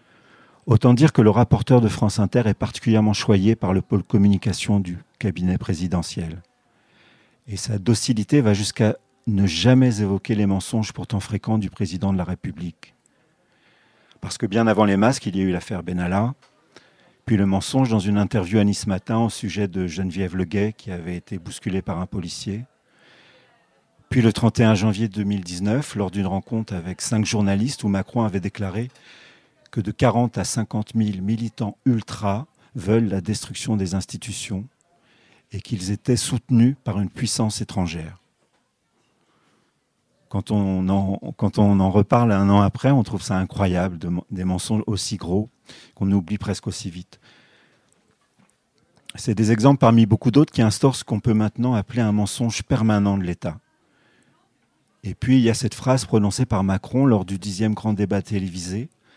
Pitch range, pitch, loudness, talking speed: 95-115 Hz, 105 Hz, -21 LUFS, 165 wpm